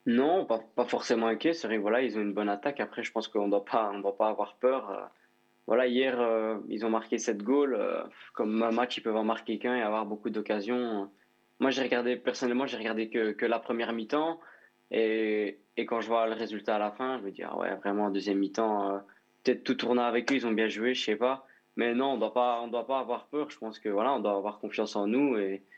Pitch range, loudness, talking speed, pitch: 105-125 Hz, -30 LUFS, 240 wpm, 115 Hz